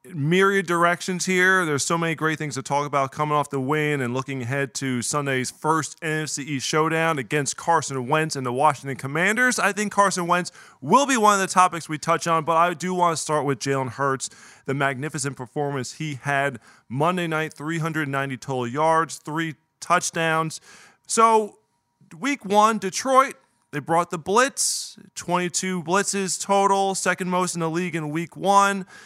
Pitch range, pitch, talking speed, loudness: 140-180 Hz, 160 Hz, 170 wpm, -22 LUFS